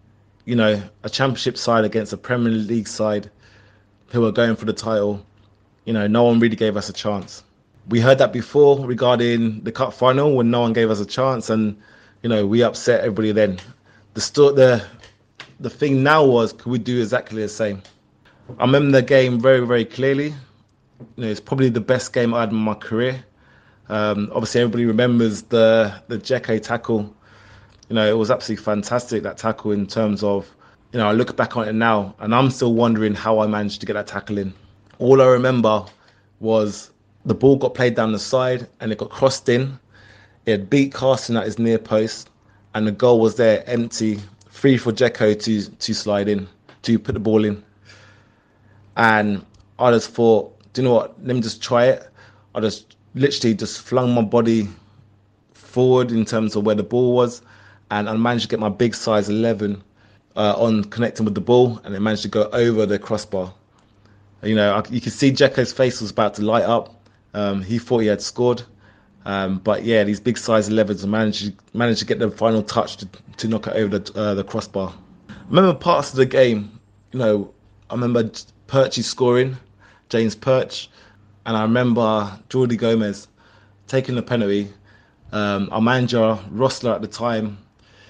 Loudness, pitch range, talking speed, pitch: -19 LUFS, 105-120 Hz, 195 wpm, 110 Hz